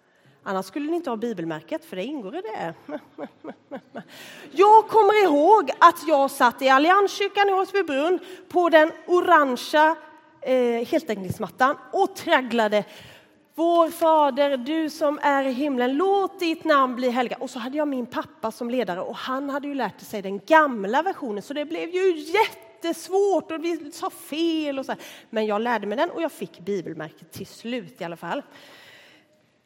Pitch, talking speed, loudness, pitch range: 295 Hz, 165 wpm, -22 LUFS, 245-335 Hz